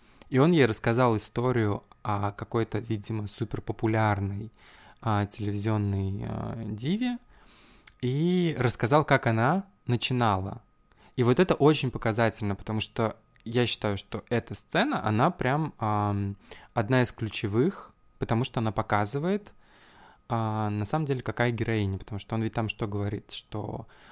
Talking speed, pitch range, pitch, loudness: 135 wpm, 105-125 Hz, 115 Hz, -28 LUFS